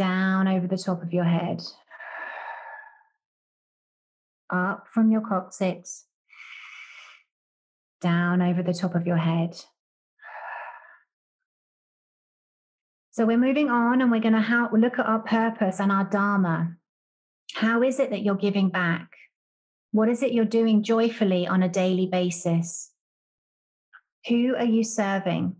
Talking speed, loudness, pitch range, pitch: 125 wpm, -24 LUFS, 180-235 Hz, 205 Hz